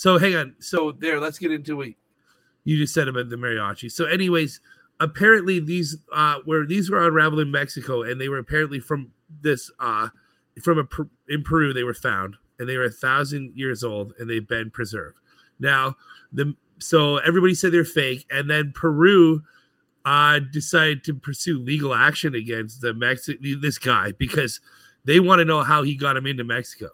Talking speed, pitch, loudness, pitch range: 185 wpm, 150 Hz, -21 LUFS, 130-160 Hz